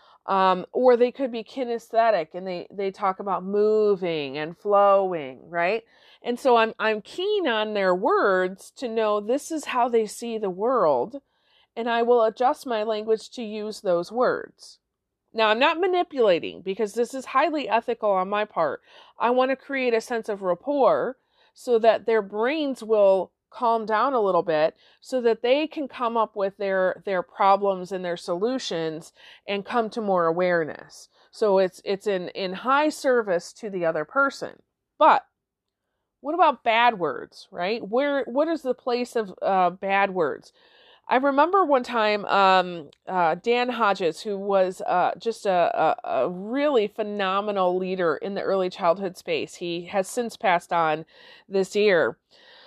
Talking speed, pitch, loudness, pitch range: 165 wpm, 215 Hz, -24 LUFS, 190-245 Hz